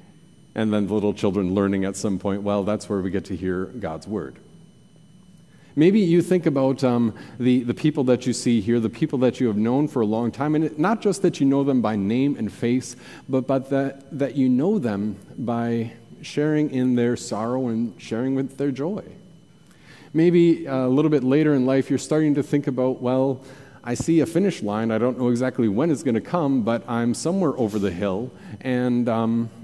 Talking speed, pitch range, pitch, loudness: 210 wpm, 115-150 Hz, 130 Hz, -22 LUFS